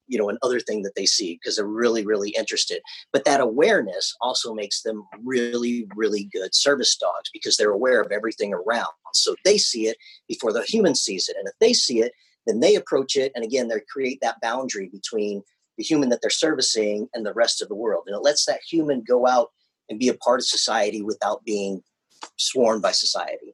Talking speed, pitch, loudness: 210 wpm, 135 Hz, -22 LUFS